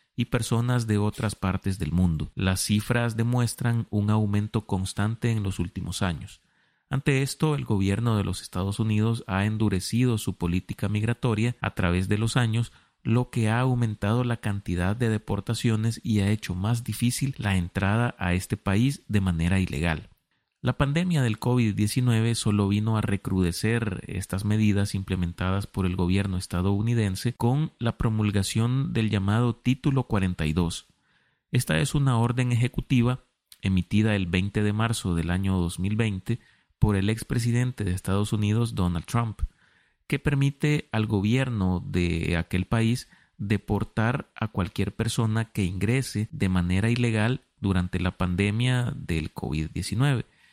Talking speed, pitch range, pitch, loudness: 145 wpm, 95-120 Hz, 105 Hz, -26 LUFS